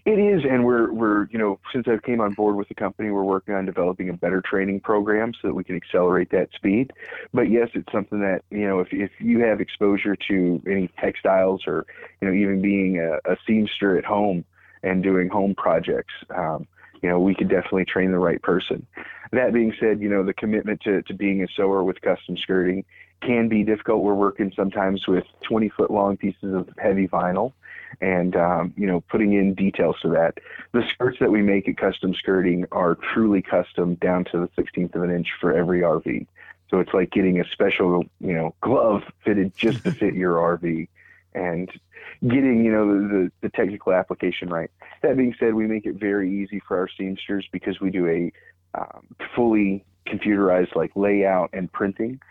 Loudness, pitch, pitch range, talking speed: -22 LUFS, 100 Hz, 95-105 Hz, 200 wpm